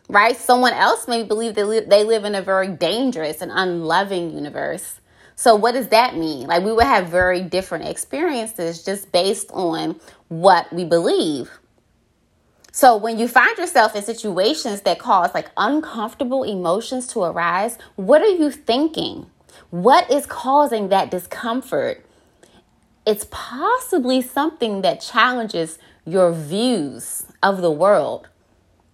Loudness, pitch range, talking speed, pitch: -19 LUFS, 175-245 Hz, 140 wpm, 210 Hz